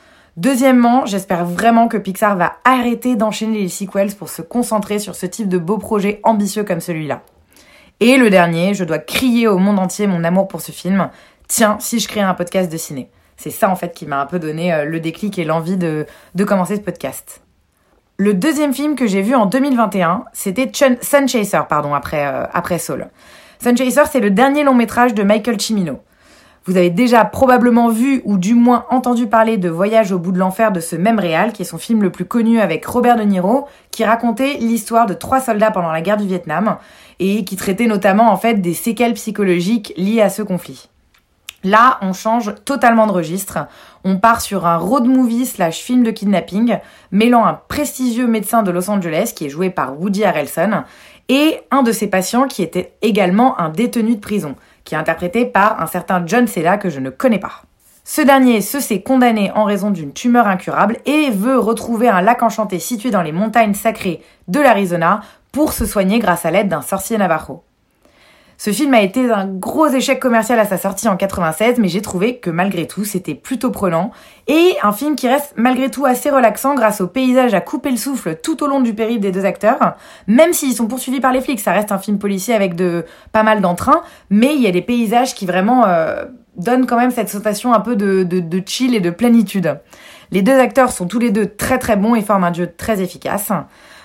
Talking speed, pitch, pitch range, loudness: 210 wpm, 215 Hz, 185-240 Hz, -15 LUFS